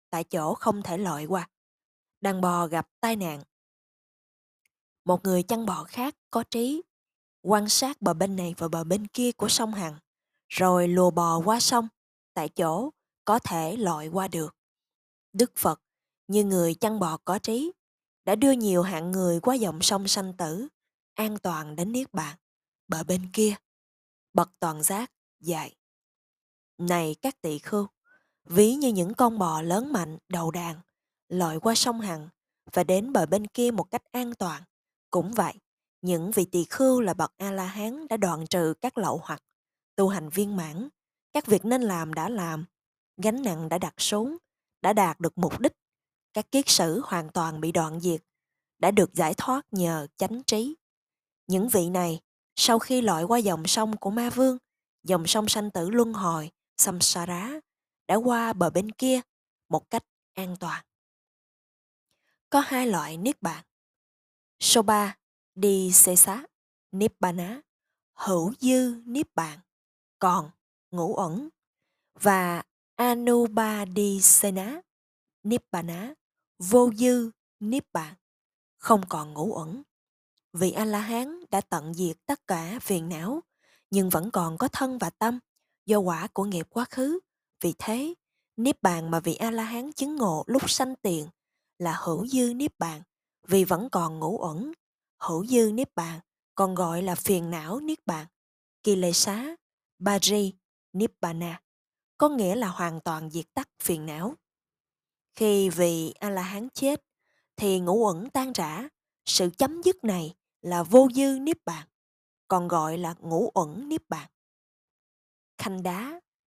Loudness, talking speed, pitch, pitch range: -26 LUFS, 160 wpm, 195 Hz, 170-235 Hz